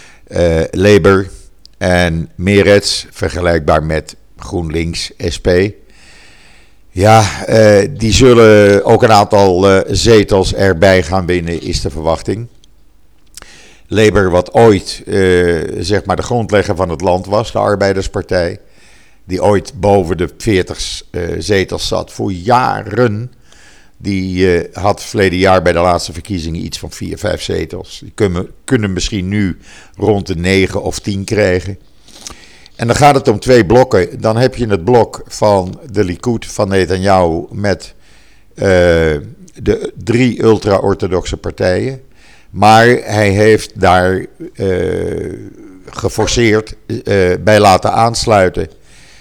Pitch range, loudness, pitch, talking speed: 90-110 Hz, -12 LUFS, 100 Hz, 125 wpm